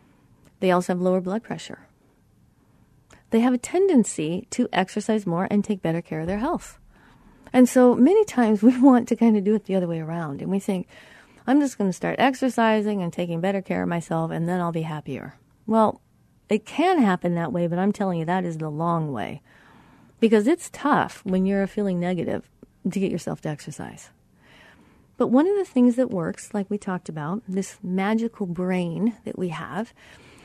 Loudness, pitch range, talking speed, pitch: -23 LUFS, 175-230 Hz, 195 wpm, 195 Hz